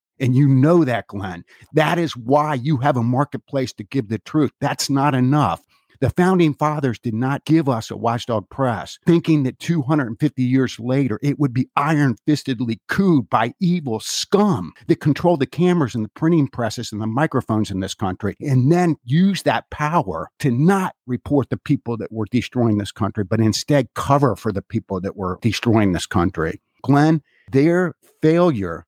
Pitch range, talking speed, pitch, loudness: 115-150 Hz, 175 wpm, 135 Hz, -19 LUFS